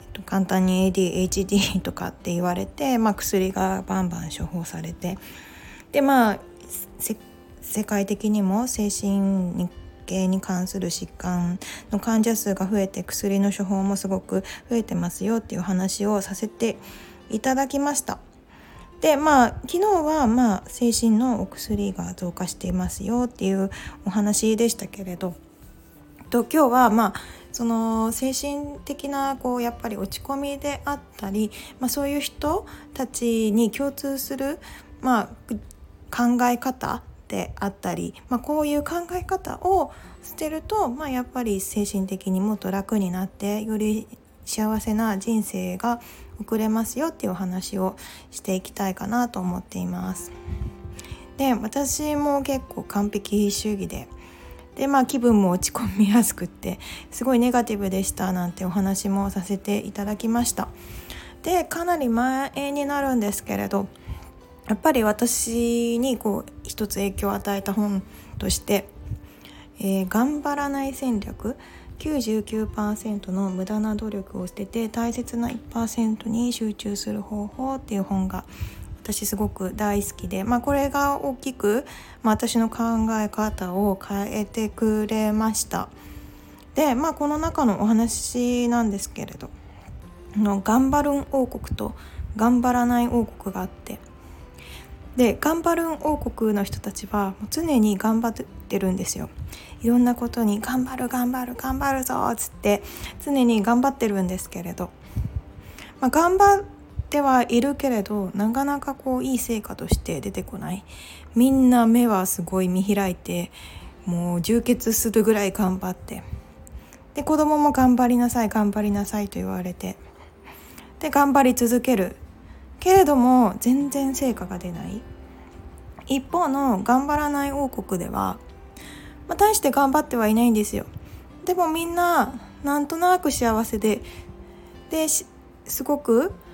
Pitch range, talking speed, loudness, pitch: 195-260 Hz, 275 characters per minute, -24 LUFS, 220 Hz